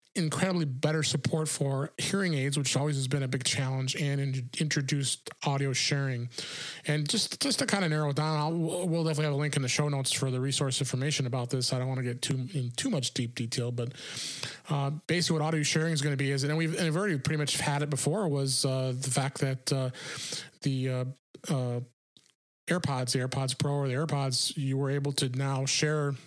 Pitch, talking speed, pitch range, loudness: 140 Hz, 220 wpm, 130-155 Hz, -30 LUFS